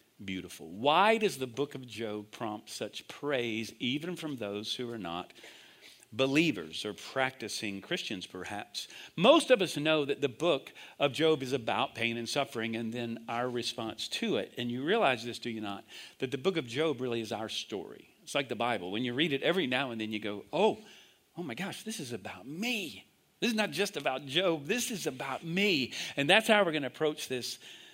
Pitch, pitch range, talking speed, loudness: 130 Hz, 115-155 Hz, 210 wpm, -32 LUFS